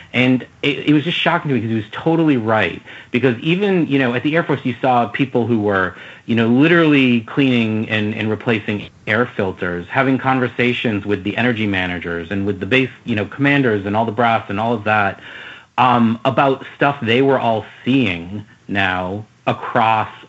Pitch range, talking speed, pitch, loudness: 105-135 Hz, 190 wpm, 120 Hz, -17 LUFS